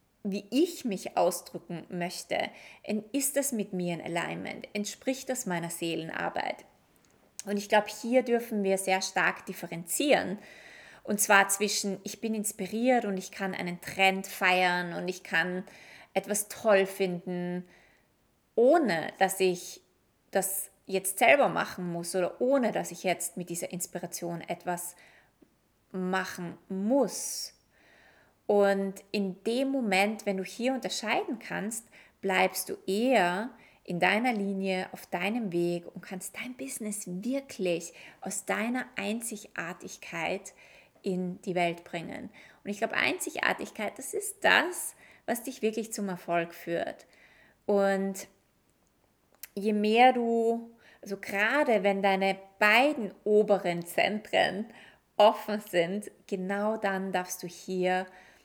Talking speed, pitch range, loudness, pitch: 125 wpm, 180-215 Hz, -29 LUFS, 195 Hz